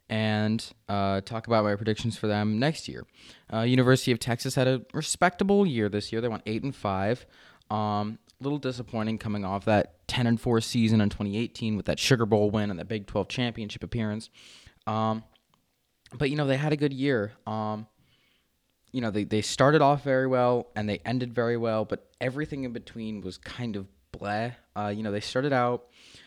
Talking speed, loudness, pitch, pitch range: 195 wpm, -28 LUFS, 110 Hz, 105-125 Hz